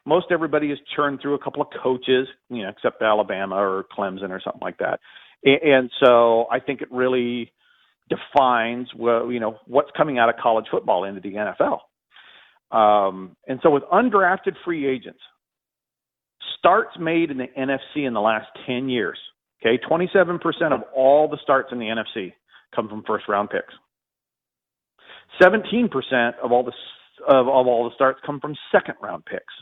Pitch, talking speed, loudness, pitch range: 130 Hz, 165 wpm, -21 LUFS, 115-145 Hz